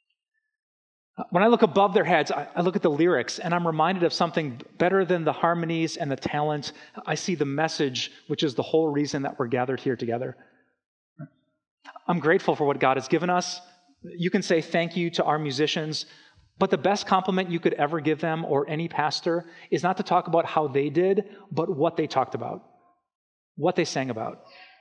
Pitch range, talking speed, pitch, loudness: 150-180 Hz, 200 wpm, 165 Hz, -25 LUFS